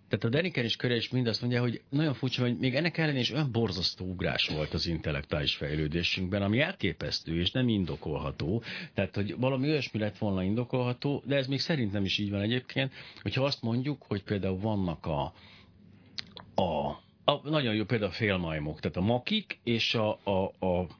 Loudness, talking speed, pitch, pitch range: -30 LUFS, 180 wpm, 110 Hz, 95-130 Hz